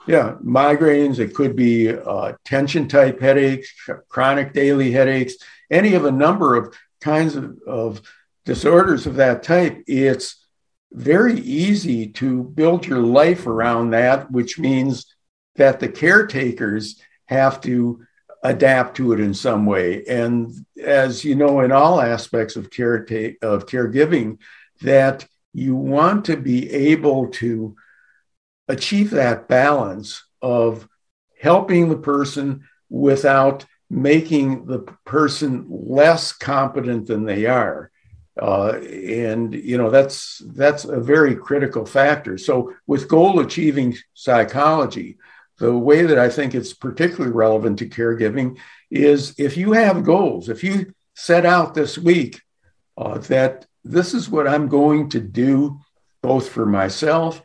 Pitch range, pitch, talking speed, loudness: 120-150 Hz, 135 Hz, 135 wpm, -18 LUFS